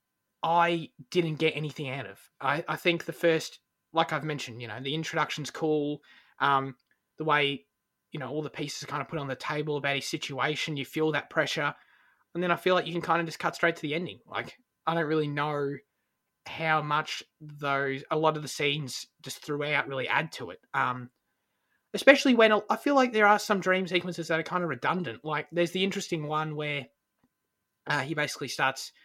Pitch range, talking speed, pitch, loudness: 145-170 Hz, 210 wpm, 155 Hz, -28 LUFS